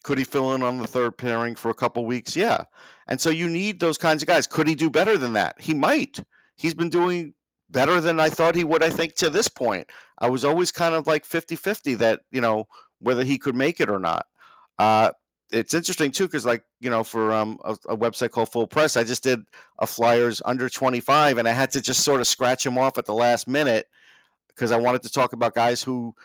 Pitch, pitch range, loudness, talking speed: 125 Hz, 120-160 Hz, -23 LUFS, 240 wpm